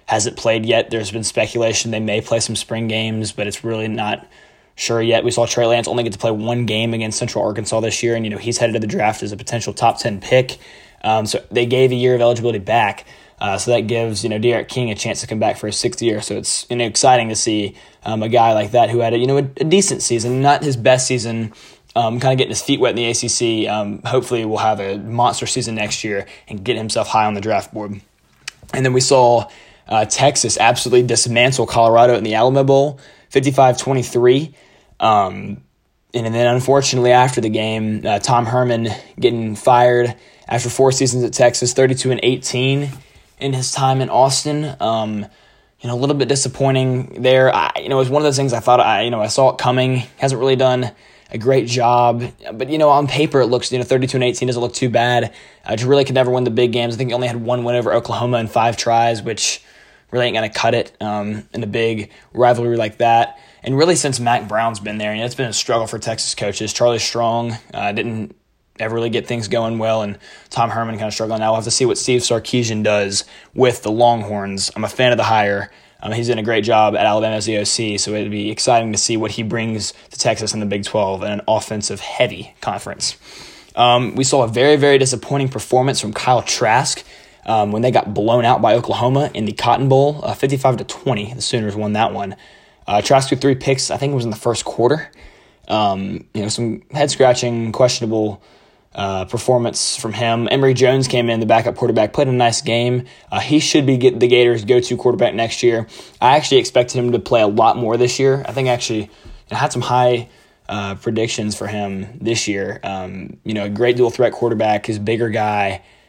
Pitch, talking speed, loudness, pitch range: 120 Hz, 230 wpm, -17 LUFS, 110-125 Hz